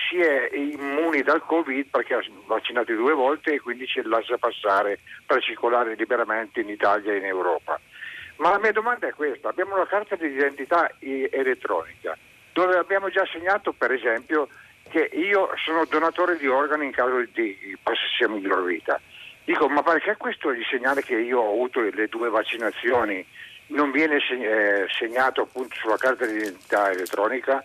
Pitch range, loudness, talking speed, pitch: 130-190 Hz, -24 LUFS, 165 wpm, 150 Hz